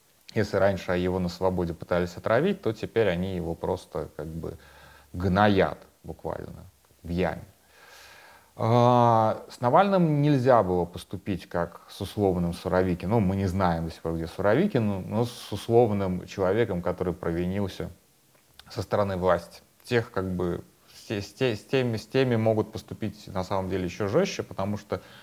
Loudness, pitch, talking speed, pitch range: -26 LUFS, 95 Hz, 150 wpm, 90-110 Hz